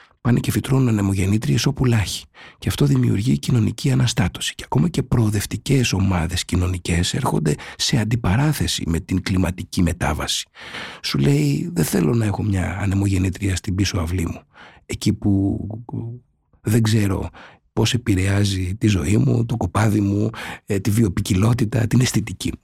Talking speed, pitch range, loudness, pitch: 135 wpm, 95-120 Hz, -20 LUFS, 105 Hz